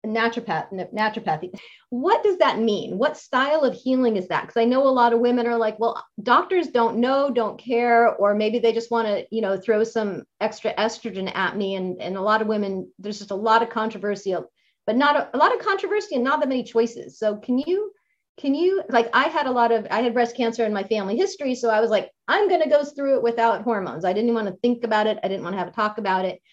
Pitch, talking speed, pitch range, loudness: 230 Hz, 255 wpm, 210-260 Hz, -22 LUFS